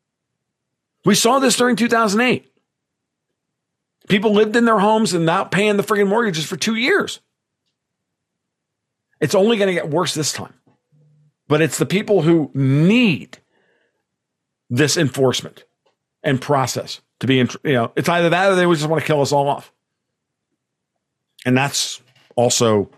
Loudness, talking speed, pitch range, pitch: -17 LUFS, 145 wpm, 140-205 Hz, 165 Hz